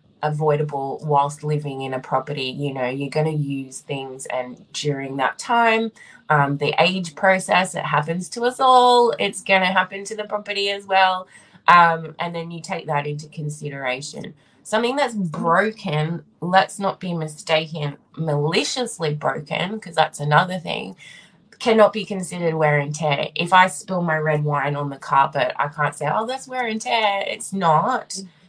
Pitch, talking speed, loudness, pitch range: 165 Hz, 170 wpm, -21 LUFS, 145-195 Hz